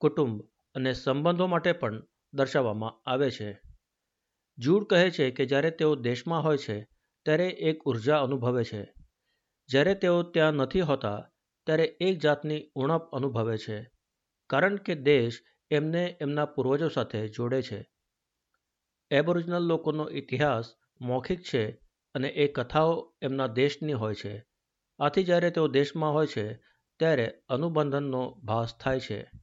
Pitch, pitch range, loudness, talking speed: 140 Hz, 120-160 Hz, -28 LUFS, 135 wpm